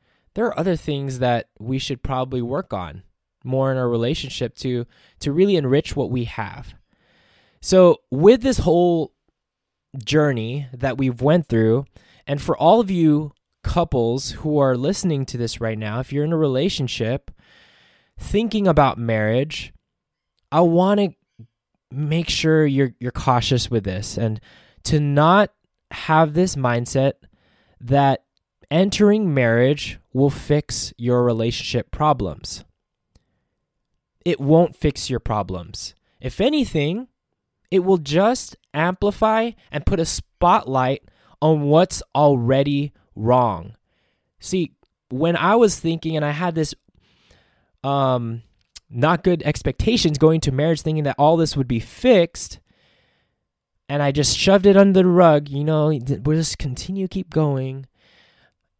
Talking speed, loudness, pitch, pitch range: 135 wpm, -19 LUFS, 140 Hz, 120-165 Hz